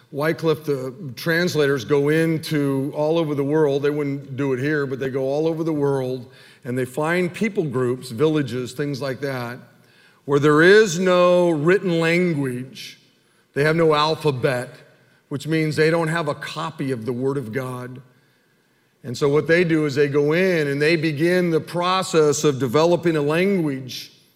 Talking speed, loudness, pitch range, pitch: 170 wpm, -20 LUFS, 135-165 Hz, 150 Hz